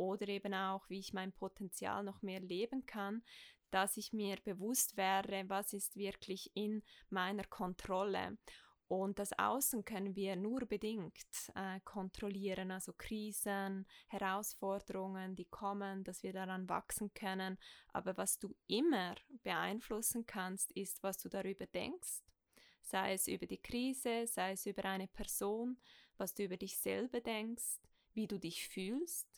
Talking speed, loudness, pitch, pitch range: 145 wpm, -42 LUFS, 200 Hz, 190-215 Hz